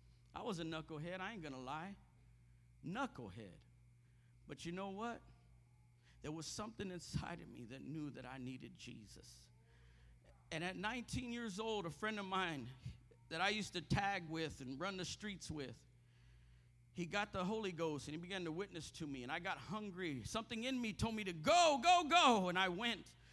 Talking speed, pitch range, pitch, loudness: 190 wpm, 120-200 Hz, 160 Hz, -41 LUFS